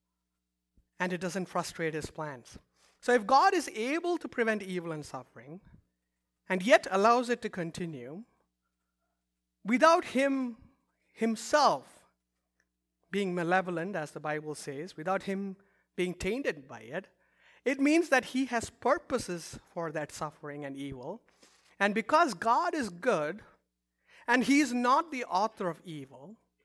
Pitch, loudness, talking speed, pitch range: 180 Hz, -30 LUFS, 135 wpm, 145-240 Hz